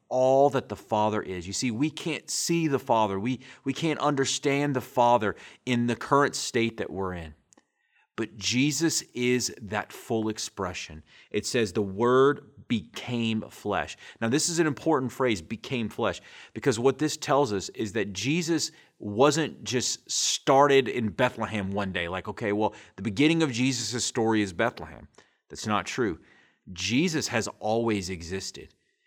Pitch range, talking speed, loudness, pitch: 105-135 Hz, 160 wpm, -27 LUFS, 120 Hz